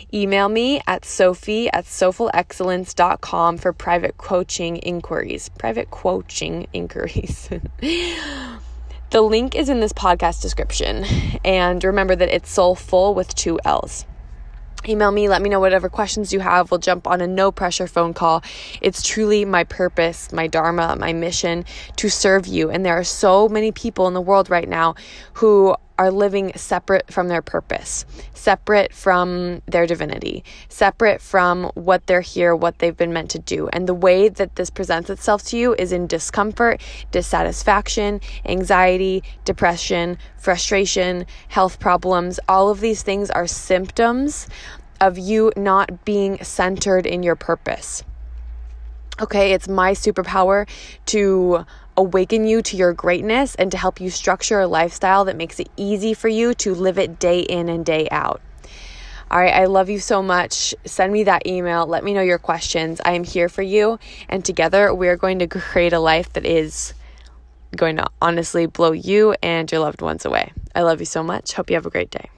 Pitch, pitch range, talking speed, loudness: 185 Hz, 170-200 Hz, 170 wpm, -18 LUFS